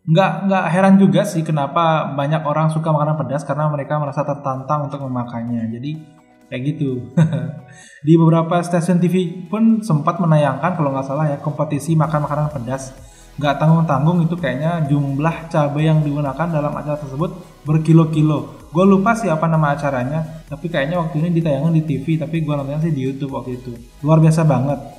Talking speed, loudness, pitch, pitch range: 170 wpm, -18 LUFS, 150 Hz, 140-165 Hz